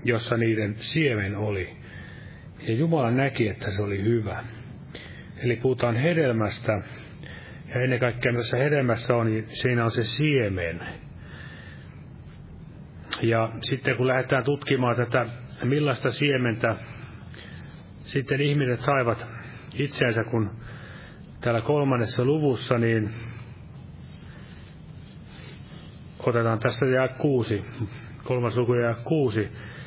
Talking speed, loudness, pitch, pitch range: 100 wpm, -25 LUFS, 120 Hz, 115-130 Hz